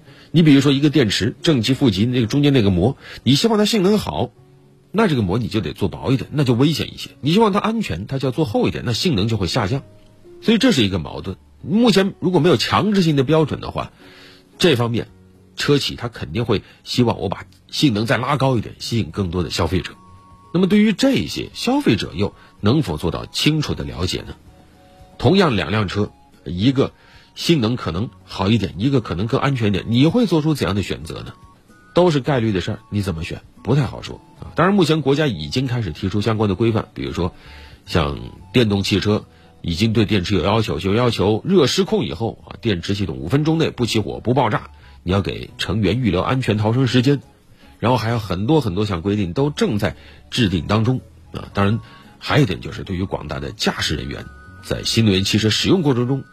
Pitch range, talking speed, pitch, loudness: 95-140 Hz, 315 characters per minute, 115 Hz, -19 LUFS